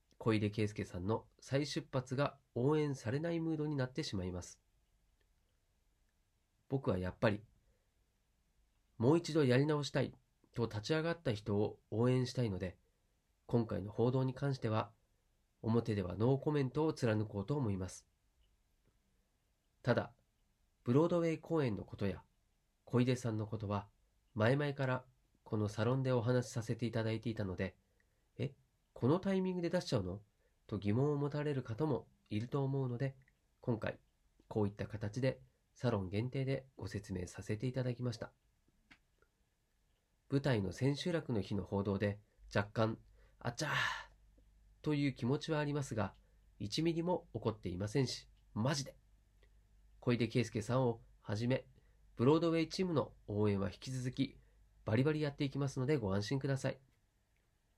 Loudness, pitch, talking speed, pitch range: -38 LUFS, 115 Hz, 305 characters per minute, 100-135 Hz